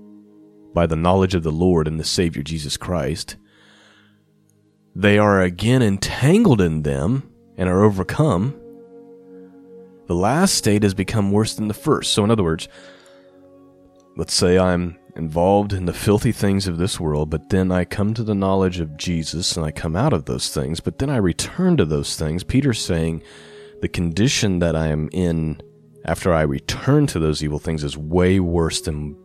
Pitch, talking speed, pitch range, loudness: 95 Hz, 175 wpm, 80-105 Hz, -20 LUFS